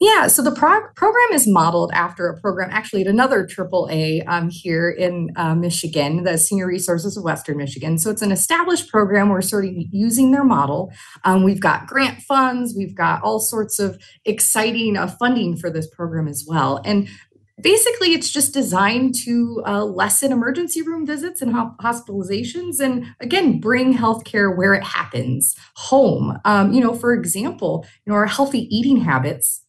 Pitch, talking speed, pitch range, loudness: 210 Hz, 175 wpm, 180-255 Hz, -18 LUFS